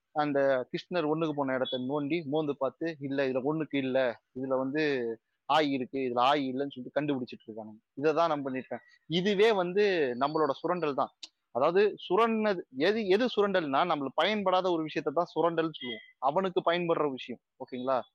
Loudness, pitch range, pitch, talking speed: -30 LUFS, 130-170 Hz, 150 Hz, 160 wpm